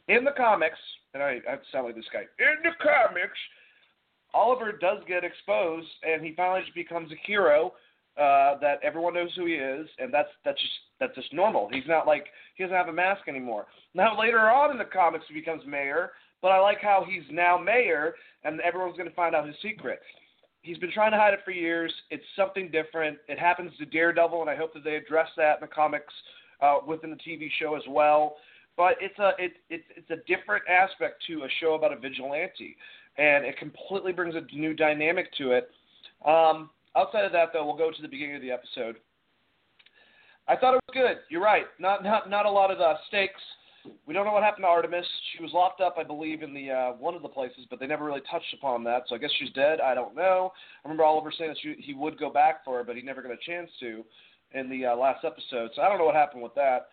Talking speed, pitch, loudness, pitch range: 235 wpm, 165 Hz, -26 LUFS, 150-195 Hz